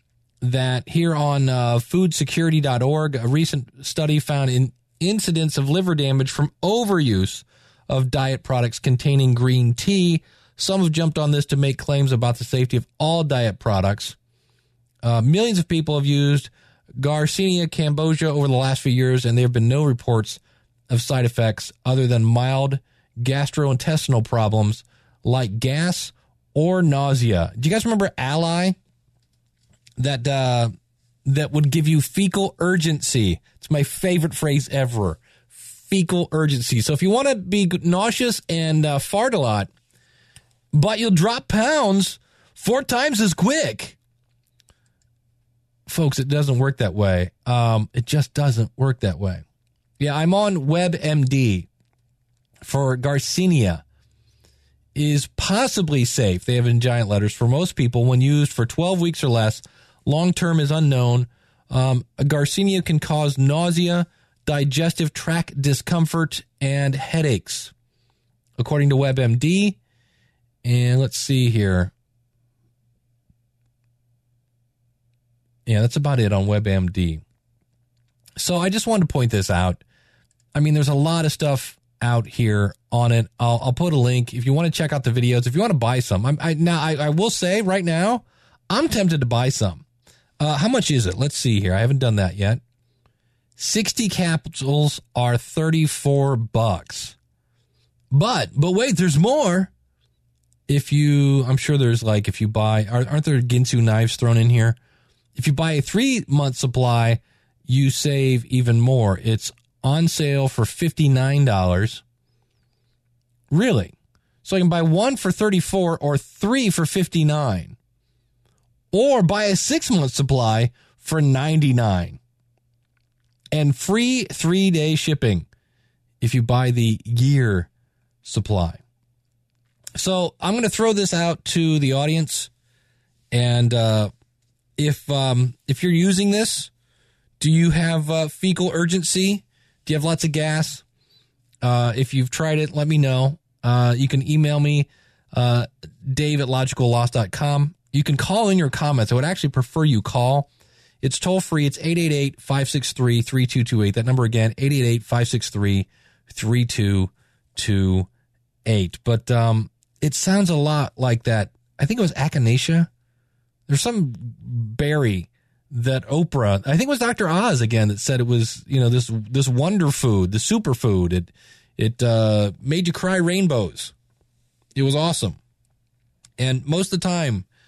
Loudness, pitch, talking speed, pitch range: -20 LUFS, 130 Hz, 145 wpm, 120-155 Hz